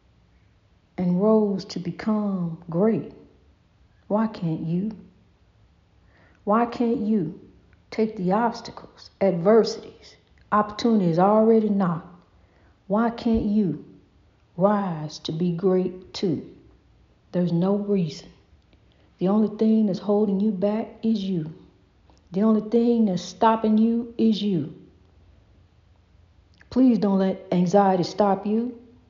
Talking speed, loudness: 105 wpm, -23 LUFS